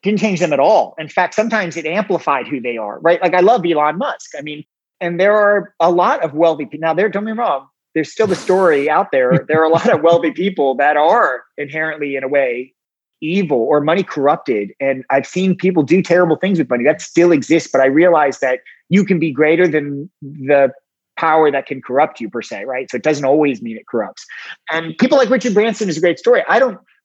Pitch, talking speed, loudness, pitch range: 160 Hz, 235 wpm, -15 LUFS, 145-185 Hz